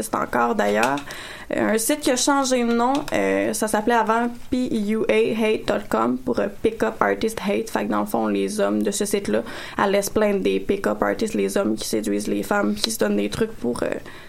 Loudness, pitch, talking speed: -22 LUFS, 200 Hz, 200 wpm